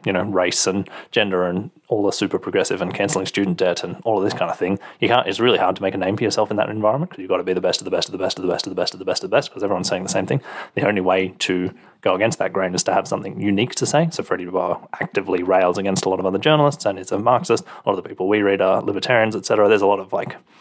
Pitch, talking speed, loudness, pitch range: 95 Hz, 325 wpm, -20 LUFS, 95-105 Hz